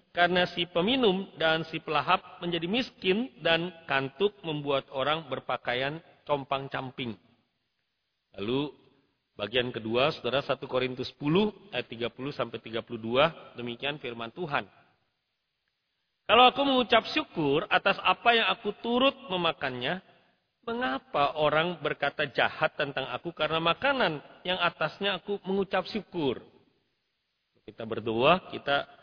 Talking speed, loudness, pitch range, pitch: 110 wpm, -28 LUFS, 135-190 Hz, 160 Hz